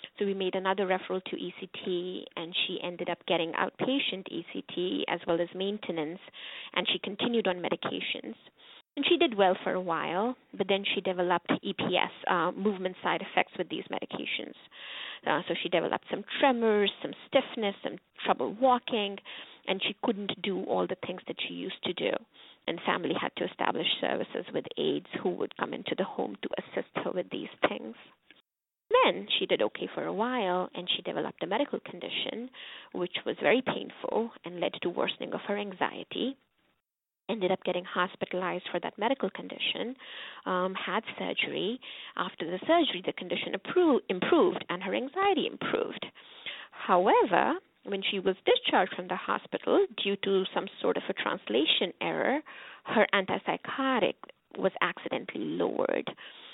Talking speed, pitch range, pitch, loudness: 160 wpm, 185-260 Hz, 200 Hz, -30 LUFS